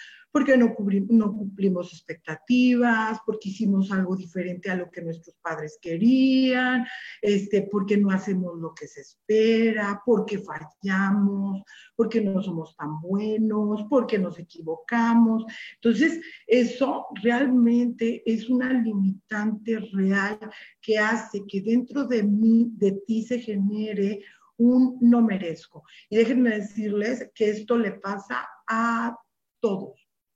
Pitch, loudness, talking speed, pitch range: 215 Hz, -24 LUFS, 125 wpm, 195-235 Hz